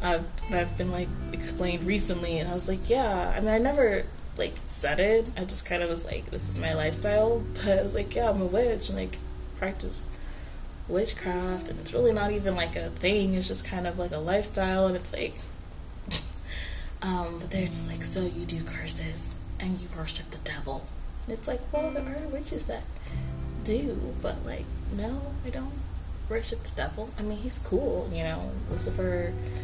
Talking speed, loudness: 195 wpm, -27 LUFS